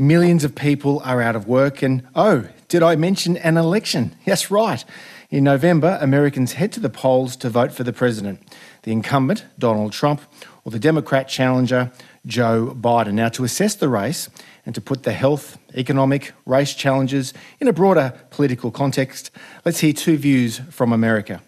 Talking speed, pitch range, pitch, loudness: 175 wpm, 125-155 Hz, 135 Hz, -19 LUFS